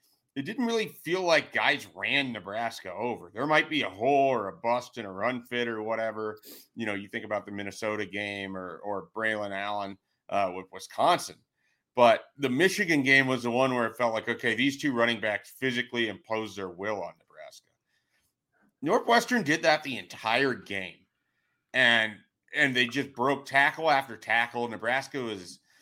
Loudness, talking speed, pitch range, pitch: -28 LUFS, 175 wpm, 105-135 Hz, 115 Hz